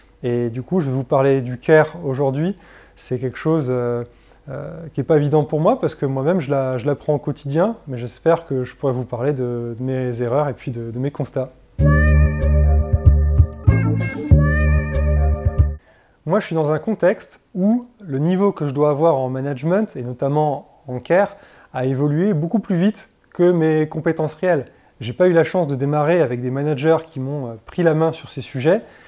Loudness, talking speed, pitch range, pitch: -19 LUFS, 190 wpm, 125-160 Hz, 140 Hz